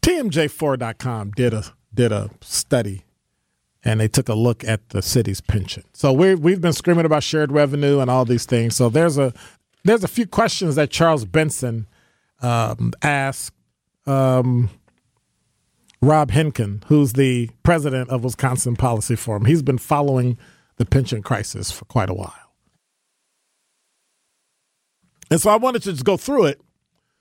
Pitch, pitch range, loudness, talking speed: 125 Hz, 115-150 Hz, -19 LUFS, 150 wpm